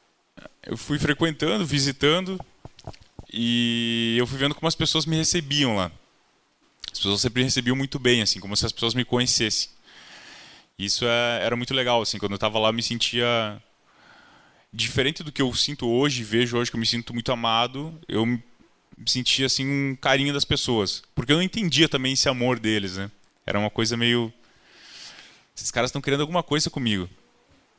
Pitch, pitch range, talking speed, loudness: 125 Hz, 115-140 Hz, 180 wpm, -23 LUFS